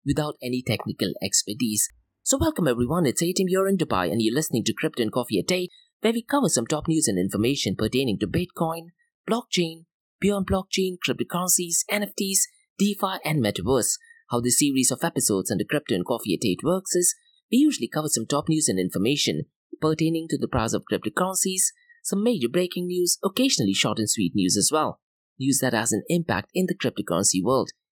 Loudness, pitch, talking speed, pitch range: -24 LUFS, 155 Hz, 185 wpm, 120-190 Hz